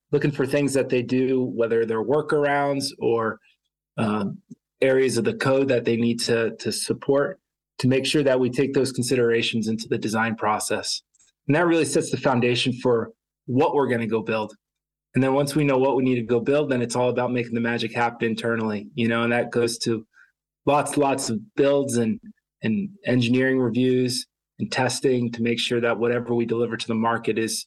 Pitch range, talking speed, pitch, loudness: 115-135 Hz, 200 wpm, 125 Hz, -23 LUFS